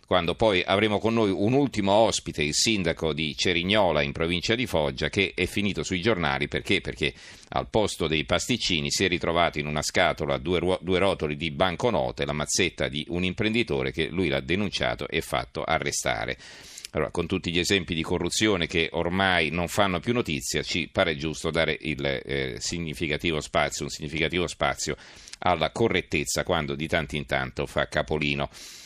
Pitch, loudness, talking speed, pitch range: 85 Hz, -25 LUFS, 170 wpm, 75-95 Hz